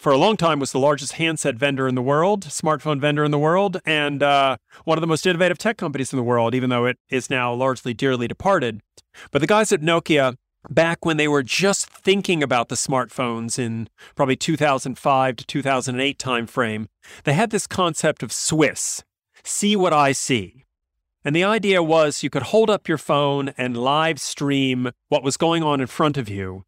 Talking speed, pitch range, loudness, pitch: 200 wpm, 125-165 Hz, -20 LUFS, 140 Hz